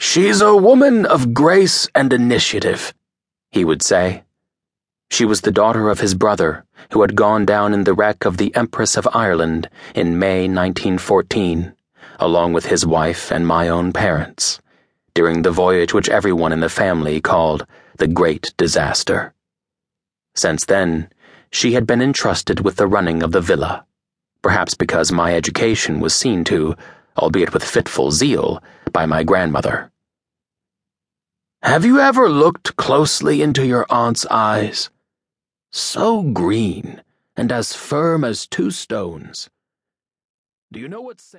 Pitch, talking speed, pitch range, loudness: 100 Hz, 145 wpm, 85-125 Hz, -16 LUFS